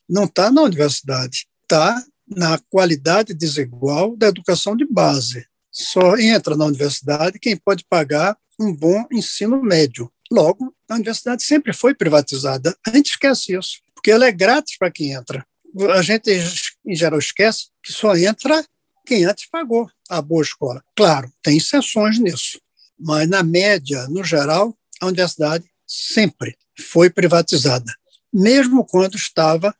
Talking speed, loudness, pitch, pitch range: 145 wpm, -17 LUFS, 185 Hz, 155-220 Hz